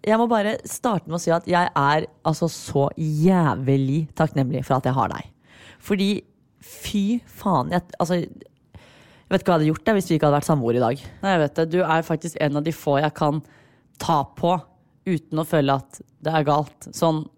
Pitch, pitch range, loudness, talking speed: 160 Hz, 145-175 Hz, -22 LUFS, 215 wpm